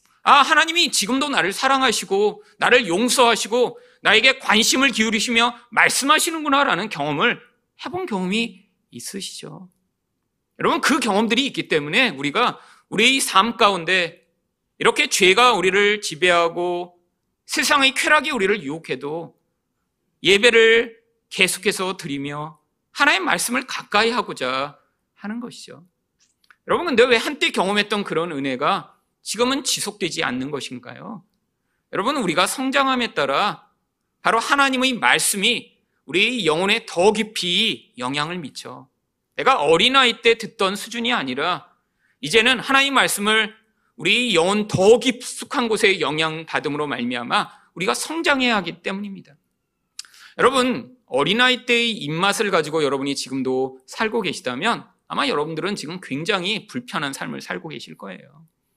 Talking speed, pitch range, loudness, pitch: 310 characters per minute, 185-250 Hz, -19 LUFS, 220 Hz